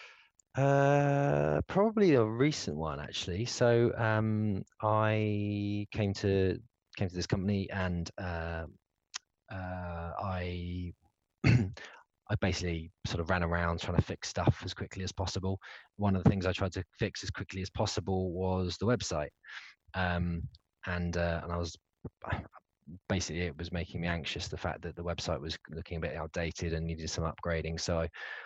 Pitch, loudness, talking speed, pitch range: 90 Hz, -33 LUFS, 160 wpm, 85-105 Hz